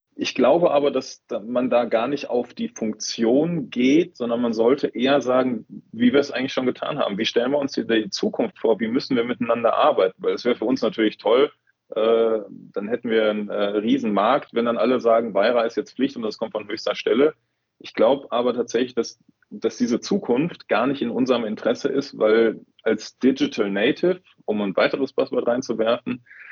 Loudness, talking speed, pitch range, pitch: -22 LUFS, 195 wpm, 115-150 Hz, 120 Hz